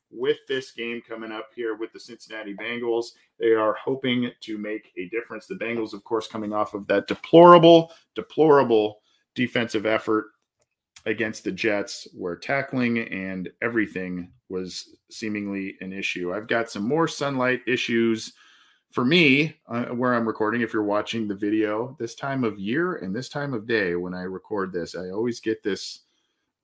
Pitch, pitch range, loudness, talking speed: 115 Hz, 105-125 Hz, -24 LUFS, 165 wpm